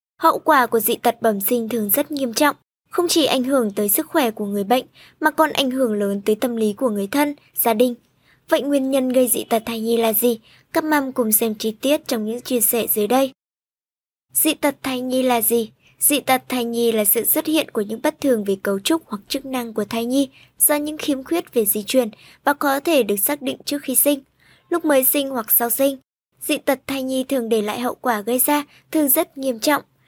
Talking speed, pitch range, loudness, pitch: 240 wpm, 230-290 Hz, -19 LUFS, 260 Hz